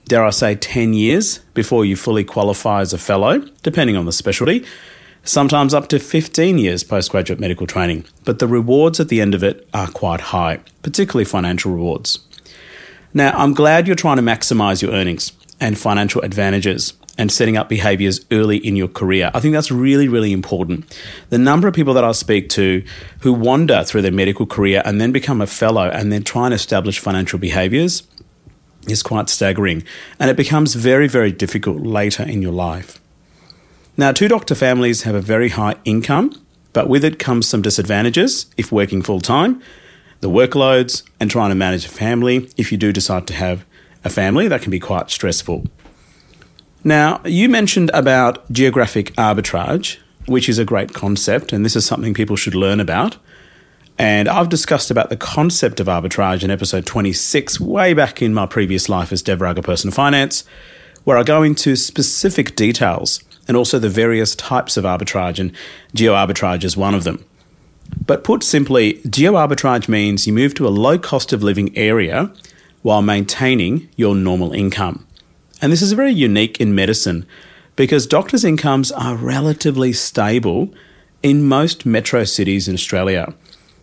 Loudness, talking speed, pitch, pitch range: -15 LUFS, 175 wpm, 110 Hz, 95-135 Hz